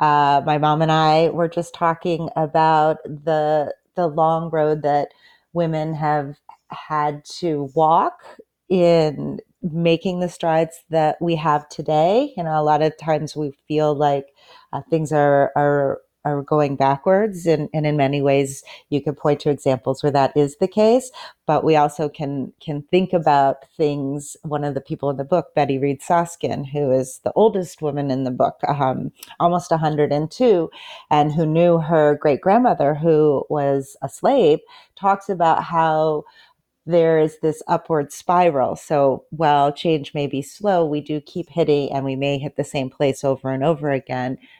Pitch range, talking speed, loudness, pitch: 145-165 Hz, 170 wpm, -19 LUFS, 150 Hz